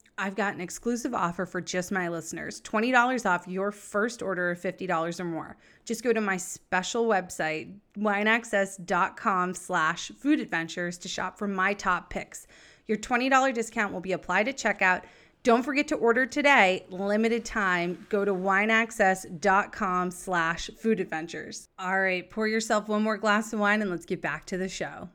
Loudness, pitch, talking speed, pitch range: -27 LUFS, 195 Hz, 170 wpm, 180-220 Hz